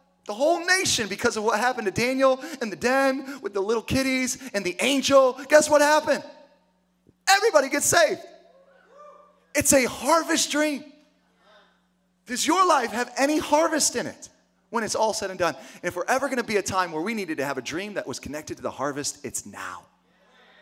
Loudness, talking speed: -23 LUFS, 195 wpm